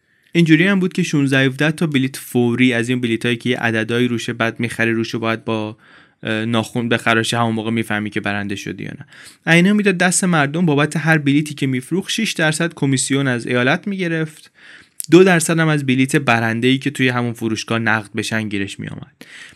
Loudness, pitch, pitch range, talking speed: -17 LUFS, 125 Hz, 115-160 Hz, 195 wpm